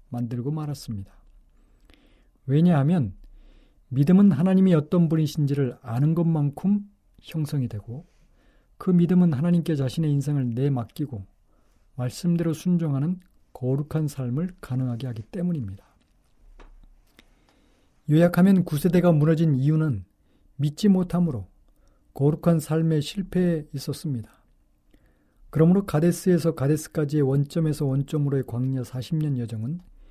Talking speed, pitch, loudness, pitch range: 280 characters per minute, 150 Hz, -24 LUFS, 130-170 Hz